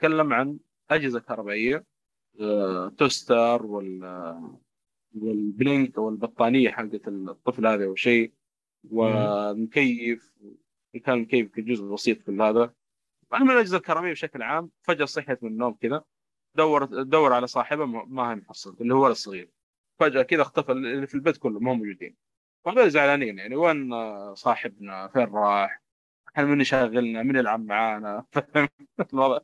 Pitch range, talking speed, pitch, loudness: 105-140 Hz, 120 wpm, 120 Hz, -24 LUFS